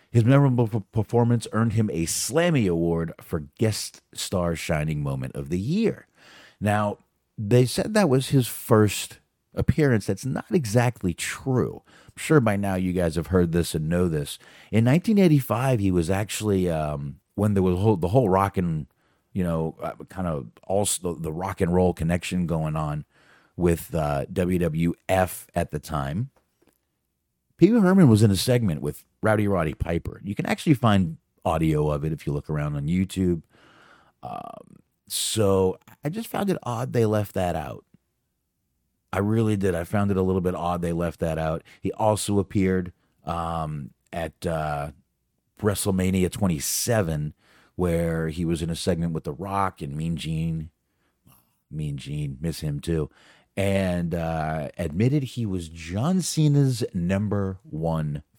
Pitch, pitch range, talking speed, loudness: 95 Hz, 80-110 Hz, 160 wpm, -24 LUFS